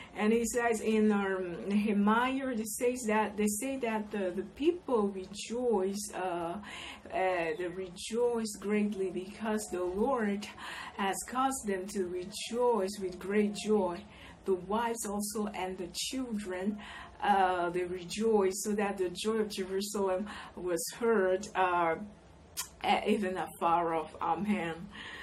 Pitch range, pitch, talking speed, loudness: 185-220 Hz, 205 Hz, 125 wpm, -33 LUFS